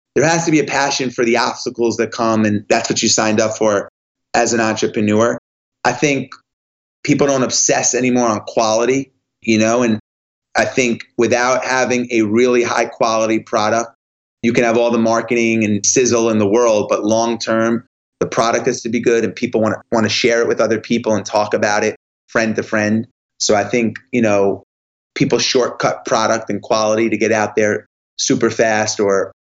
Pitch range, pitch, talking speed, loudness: 110-120 Hz, 115 Hz, 190 wpm, -16 LUFS